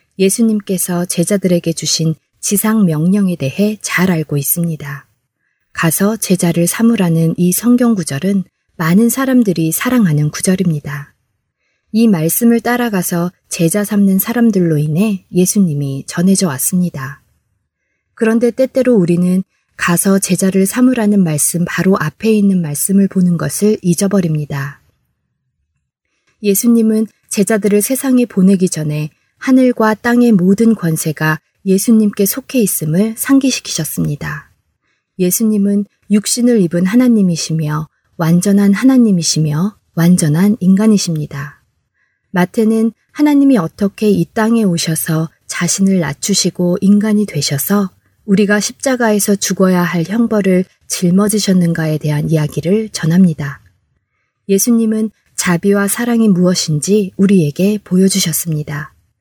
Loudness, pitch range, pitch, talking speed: -13 LUFS, 165-215 Hz, 190 Hz, 290 characters per minute